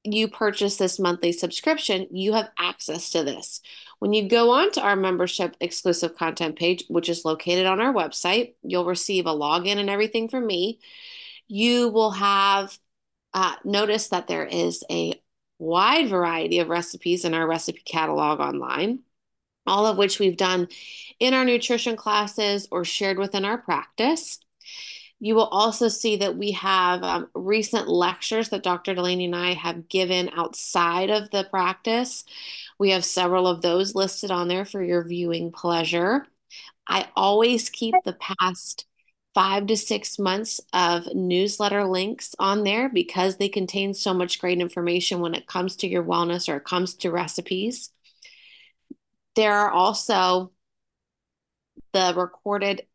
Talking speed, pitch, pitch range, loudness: 155 wpm, 190 Hz, 180-215 Hz, -23 LUFS